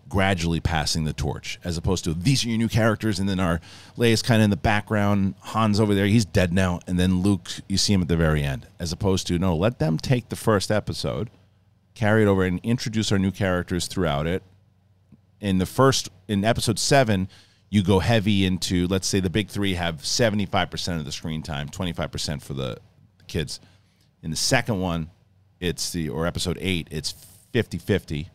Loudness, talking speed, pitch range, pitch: -23 LUFS, 200 wpm, 85-105 Hz, 95 Hz